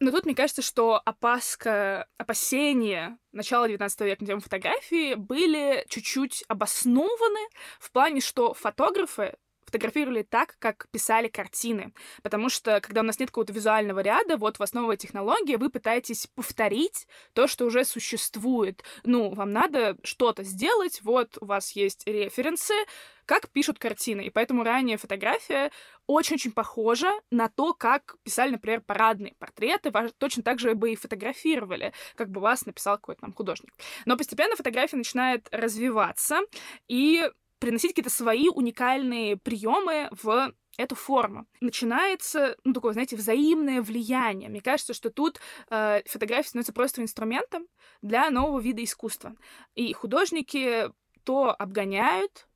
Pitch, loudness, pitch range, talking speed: 240 Hz, -27 LUFS, 220-275 Hz, 140 wpm